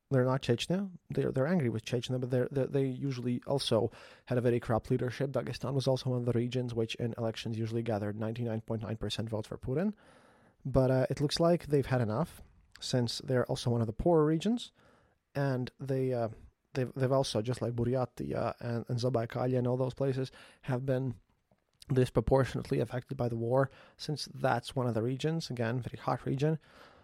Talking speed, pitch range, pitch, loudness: 190 wpm, 120-135 Hz, 125 Hz, -33 LUFS